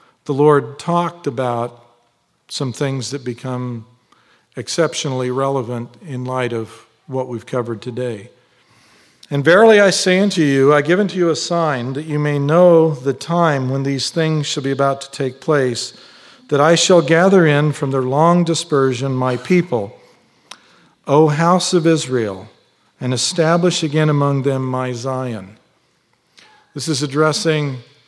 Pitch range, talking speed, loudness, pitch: 130-160 Hz, 145 wpm, -16 LUFS, 140 Hz